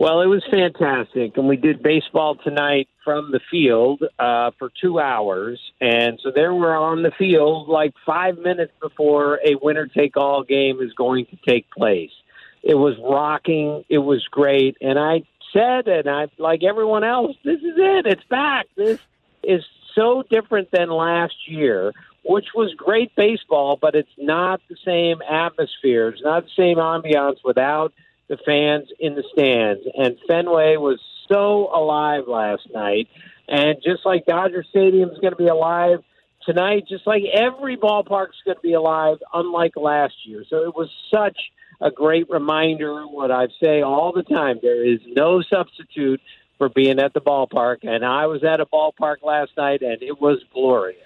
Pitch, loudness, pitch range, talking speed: 155 Hz, -19 LUFS, 140-180 Hz, 175 wpm